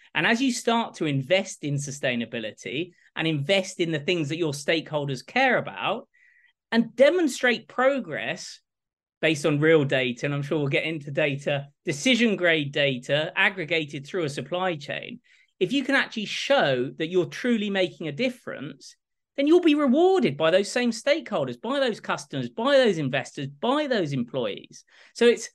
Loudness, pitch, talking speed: -24 LUFS, 180 Hz, 165 wpm